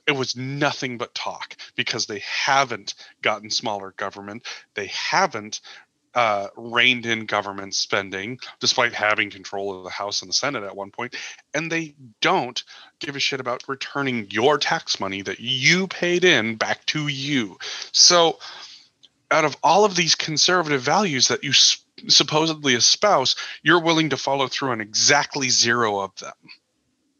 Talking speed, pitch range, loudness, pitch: 155 wpm, 105-155 Hz, -20 LUFS, 130 Hz